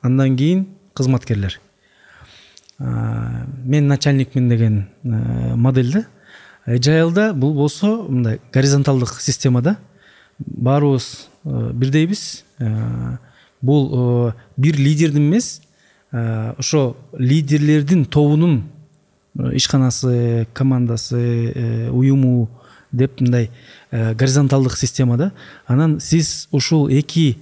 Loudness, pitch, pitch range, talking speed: -17 LUFS, 130 Hz, 120-150 Hz, 80 wpm